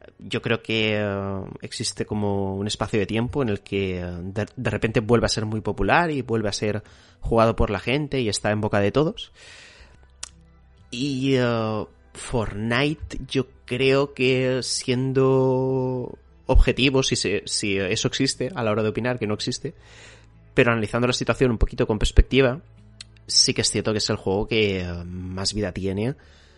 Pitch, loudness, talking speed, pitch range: 110 Hz, -23 LUFS, 175 wpm, 100-125 Hz